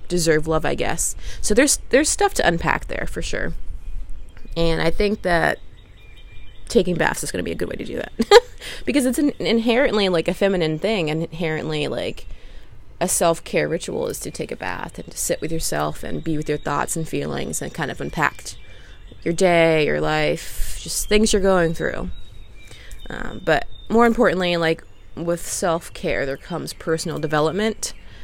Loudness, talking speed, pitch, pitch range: -21 LUFS, 185 wpm, 165 Hz, 145-195 Hz